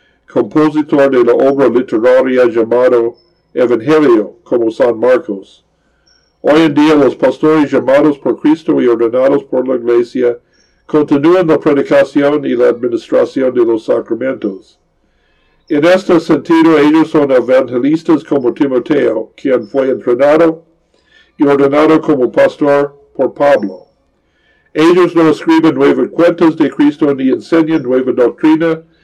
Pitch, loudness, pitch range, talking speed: 150 Hz, -11 LUFS, 130-165 Hz, 125 wpm